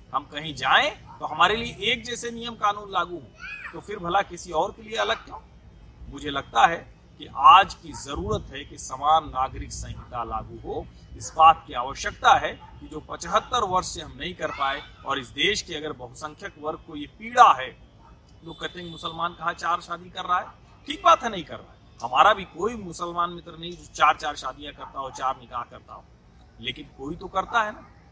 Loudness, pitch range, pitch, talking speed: -24 LUFS, 135-180 Hz, 160 Hz, 205 wpm